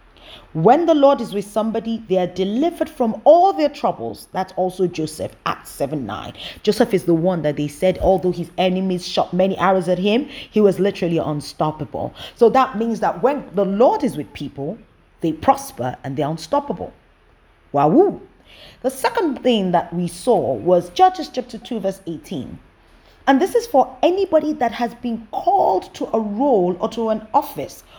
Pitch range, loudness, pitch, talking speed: 180-265 Hz, -19 LUFS, 215 Hz, 180 wpm